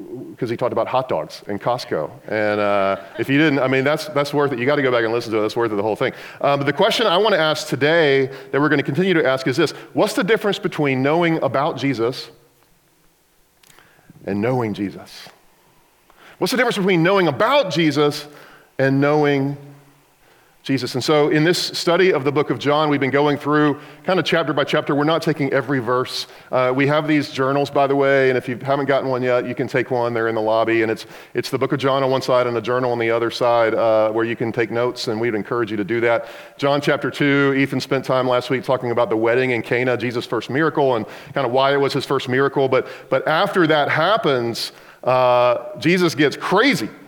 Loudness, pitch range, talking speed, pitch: -19 LUFS, 125-150 Hz, 235 wpm, 135 Hz